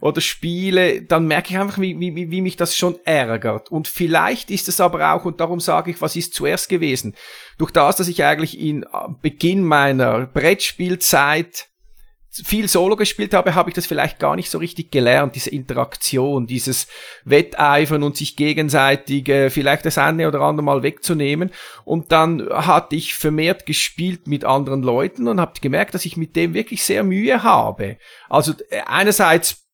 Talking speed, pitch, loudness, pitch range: 170 wpm, 165 Hz, -18 LUFS, 145-180 Hz